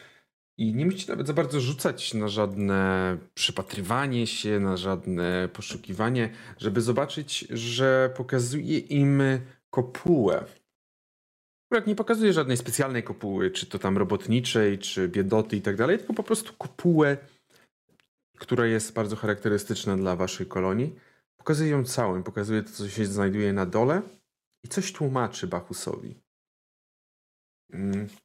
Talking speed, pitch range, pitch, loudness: 130 wpm, 100-140 Hz, 115 Hz, -27 LUFS